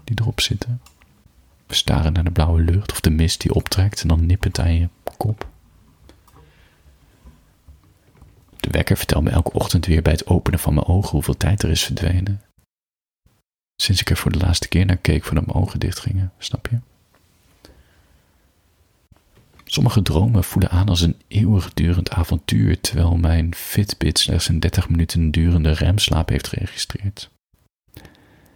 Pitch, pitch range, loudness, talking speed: 90 Hz, 80-100 Hz, -19 LUFS, 155 wpm